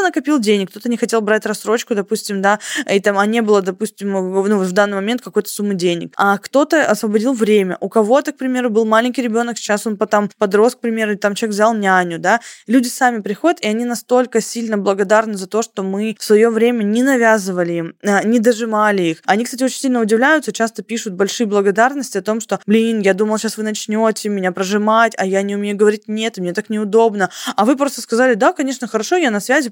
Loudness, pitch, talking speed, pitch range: -16 LUFS, 220 Hz, 215 wpm, 205-235 Hz